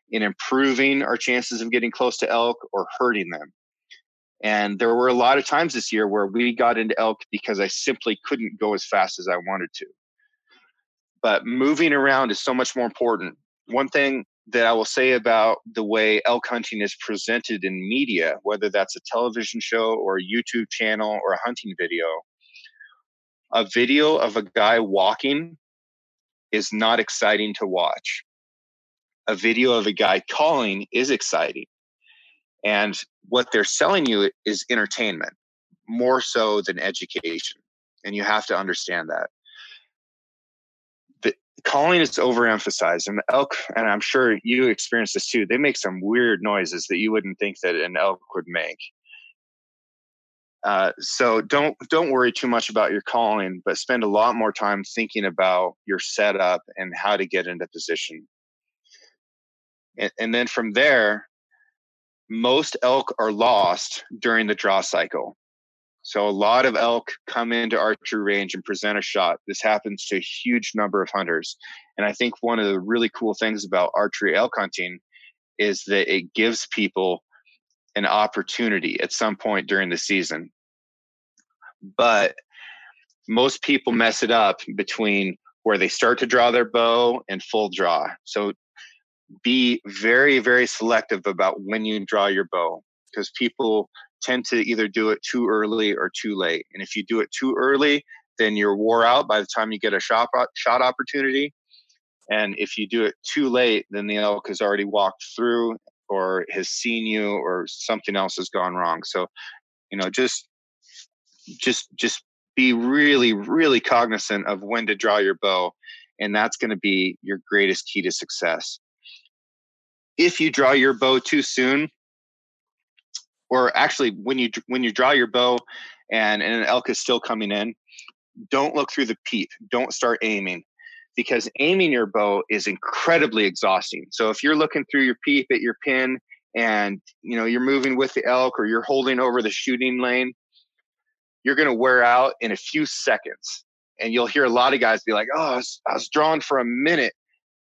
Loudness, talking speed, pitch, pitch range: -21 LUFS, 170 wpm, 115 Hz, 105-130 Hz